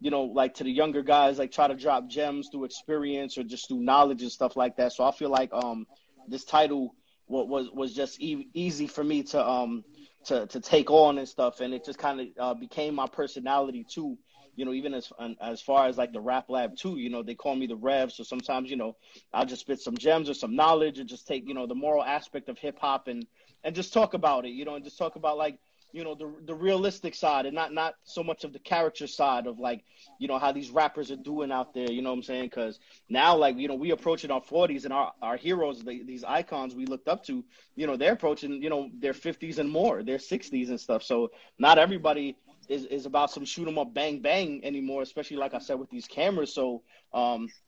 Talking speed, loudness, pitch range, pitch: 250 wpm, -28 LUFS, 130-155 Hz, 140 Hz